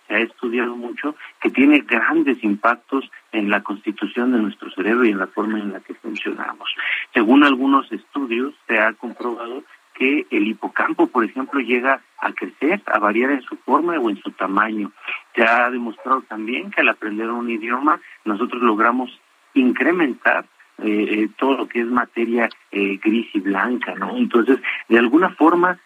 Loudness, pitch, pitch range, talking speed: -19 LUFS, 120 Hz, 110-135 Hz, 165 wpm